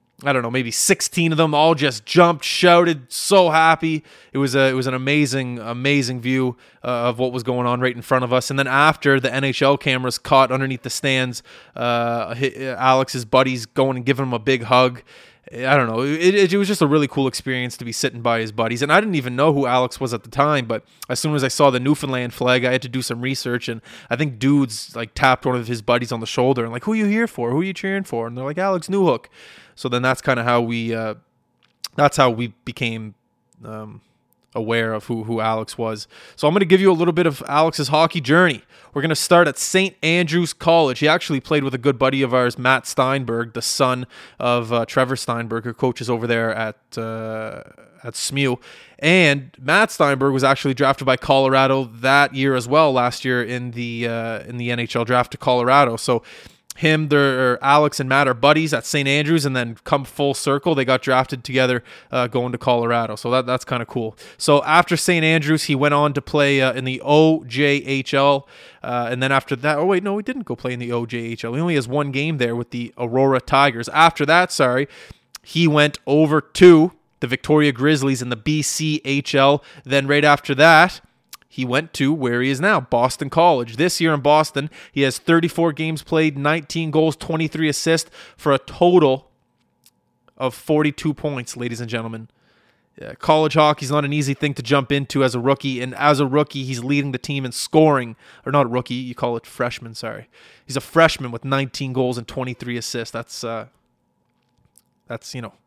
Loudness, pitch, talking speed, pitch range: -18 LUFS, 135 Hz, 215 wpm, 125-150 Hz